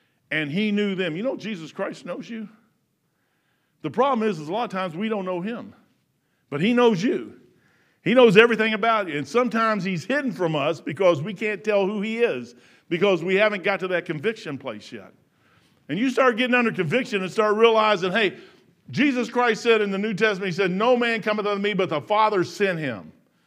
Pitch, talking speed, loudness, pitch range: 210 Hz, 210 wpm, -22 LUFS, 185-230 Hz